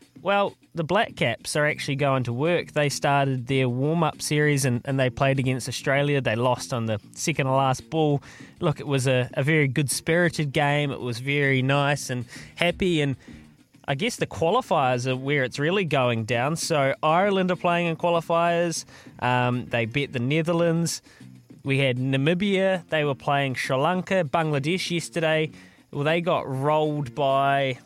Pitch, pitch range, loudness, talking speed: 140 Hz, 130-160 Hz, -24 LUFS, 170 wpm